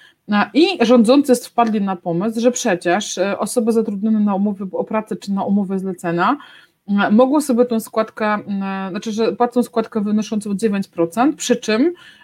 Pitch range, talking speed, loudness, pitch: 200-245 Hz, 140 wpm, -18 LUFS, 220 Hz